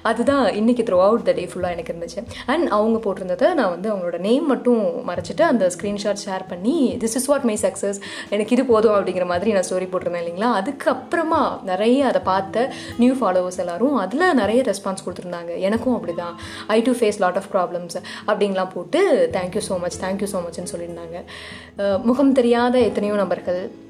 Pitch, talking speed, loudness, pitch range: 210 Hz, 170 wpm, -20 LUFS, 185-250 Hz